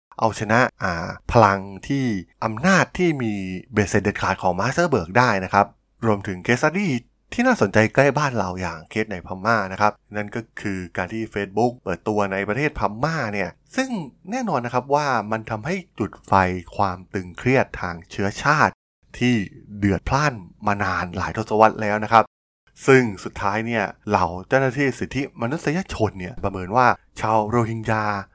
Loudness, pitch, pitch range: -22 LUFS, 110 Hz, 95-125 Hz